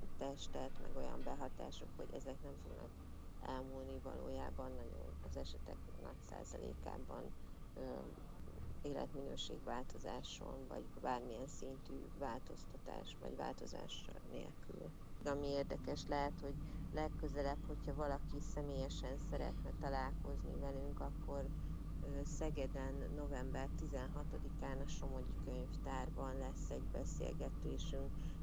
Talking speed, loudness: 95 wpm, -48 LUFS